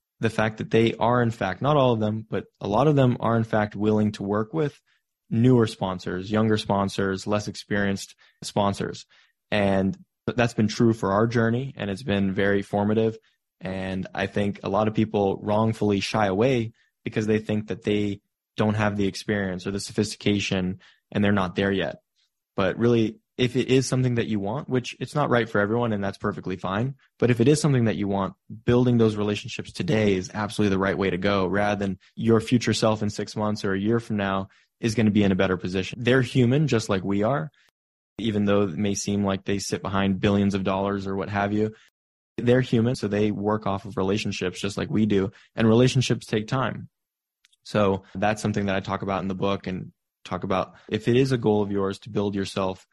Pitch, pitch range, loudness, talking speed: 105 Hz, 100-115 Hz, -24 LUFS, 215 wpm